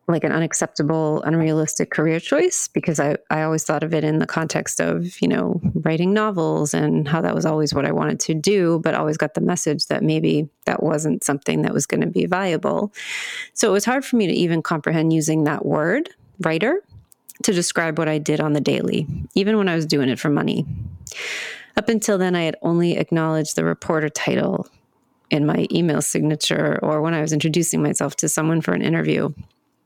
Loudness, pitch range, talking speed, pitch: -20 LUFS, 155-195 Hz, 205 wpm, 160 Hz